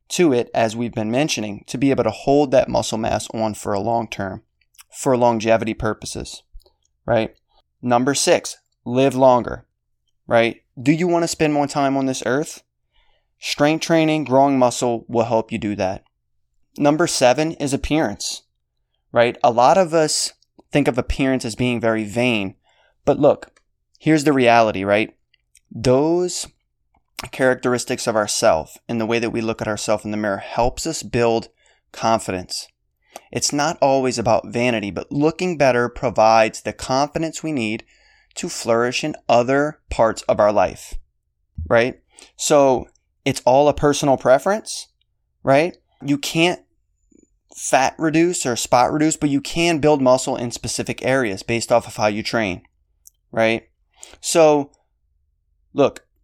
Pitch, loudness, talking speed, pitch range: 120 Hz, -19 LUFS, 150 wpm, 110-140 Hz